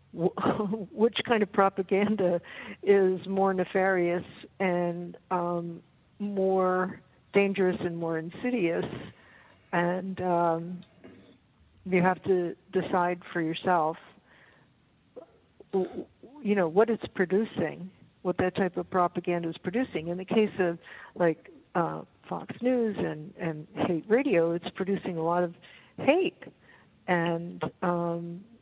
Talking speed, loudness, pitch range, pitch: 115 wpm, -29 LUFS, 175-195 Hz, 180 Hz